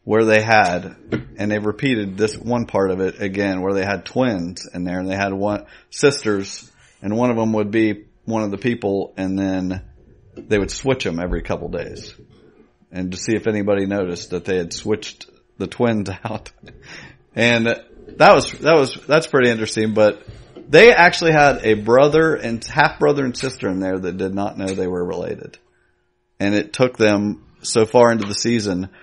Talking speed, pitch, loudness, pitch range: 190 wpm, 105 Hz, -18 LUFS, 95-115 Hz